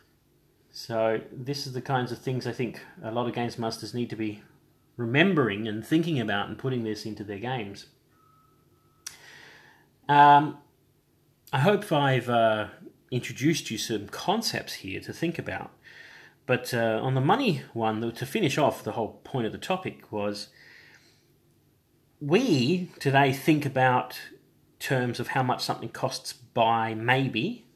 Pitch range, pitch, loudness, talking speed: 110-140 Hz, 125 Hz, -27 LUFS, 145 wpm